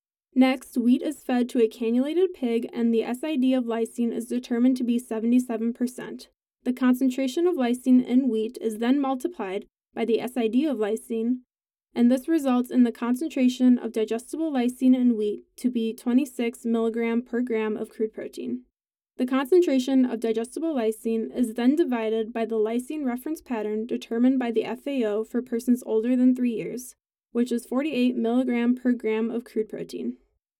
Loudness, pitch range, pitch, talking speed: -25 LUFS, 225-255 Hz, 240 Hz, 165 wpm